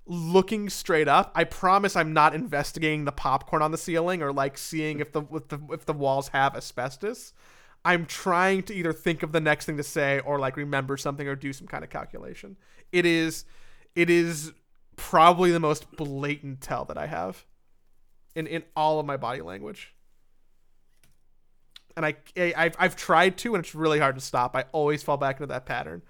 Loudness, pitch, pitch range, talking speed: -26 LUFS, 155 Hz, 140-170 Hz, 195 wpm